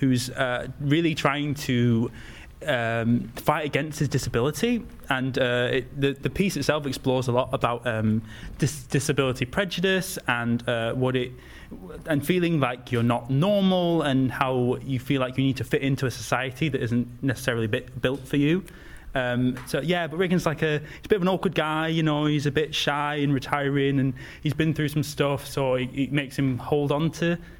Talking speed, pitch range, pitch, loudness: 195 wpm, 125-150 Hz, 140 Hz, -25 LUFS